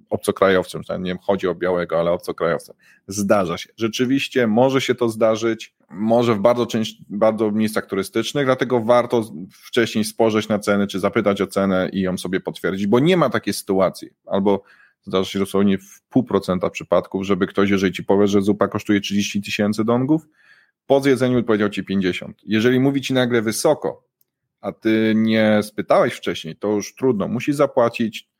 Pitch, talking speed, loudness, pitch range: 110 Hz, 170 wpm, -20 LUFS, 100-120 Hz